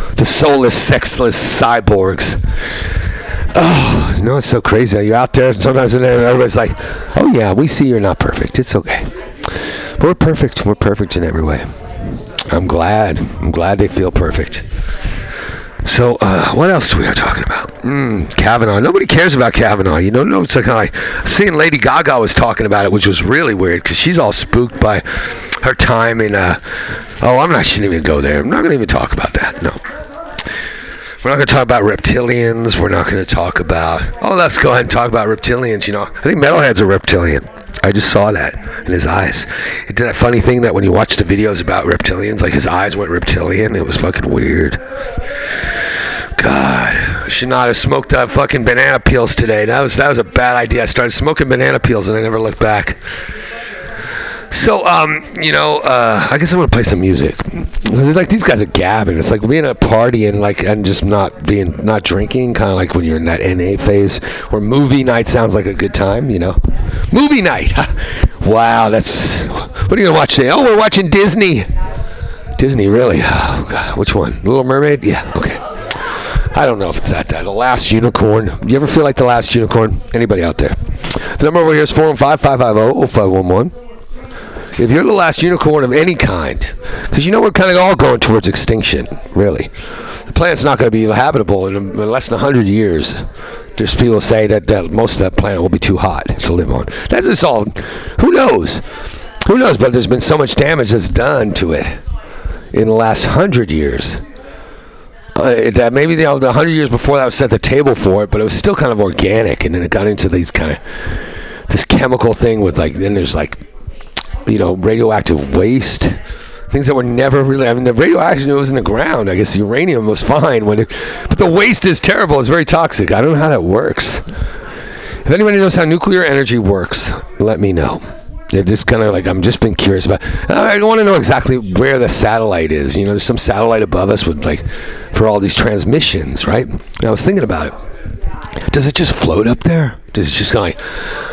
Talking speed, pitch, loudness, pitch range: 210 wpm, 110 Hz, -12 LUFS, 95-130 Hz